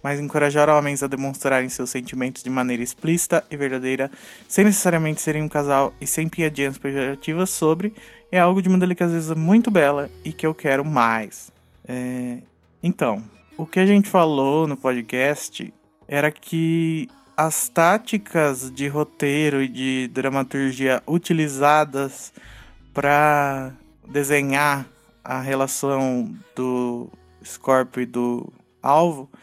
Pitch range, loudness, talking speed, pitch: 130-160 Hz, -21 LUFS, 125 wpm, 145 Hz